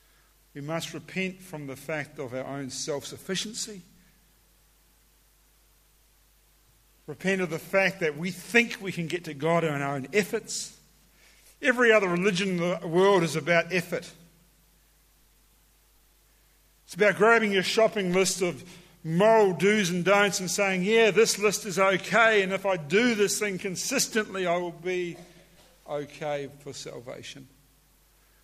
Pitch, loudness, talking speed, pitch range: 185 Hz, -25 LUFS, 140 wpm, 165-205 Hz